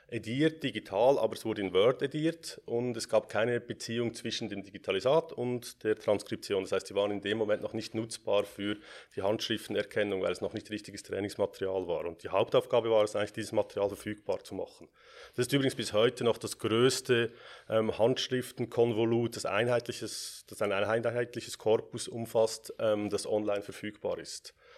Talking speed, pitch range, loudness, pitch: 170 wpm, 105-120 Hz, -32 LUFS, 110 Hz